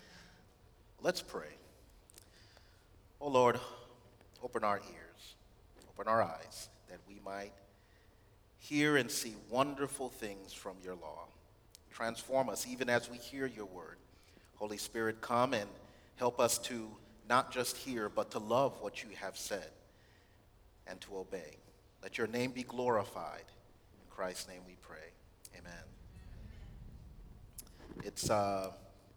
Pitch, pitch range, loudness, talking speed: 105 Hz, 95-120 Hz, -37 LUFS, 130 wpm